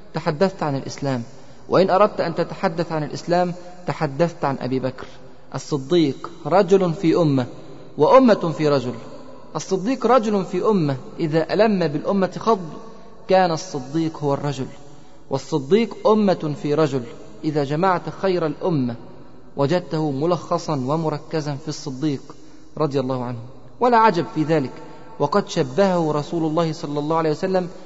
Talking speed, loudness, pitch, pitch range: 130 wpm, -21 LUFS, 155 Hz, 145-180 Hz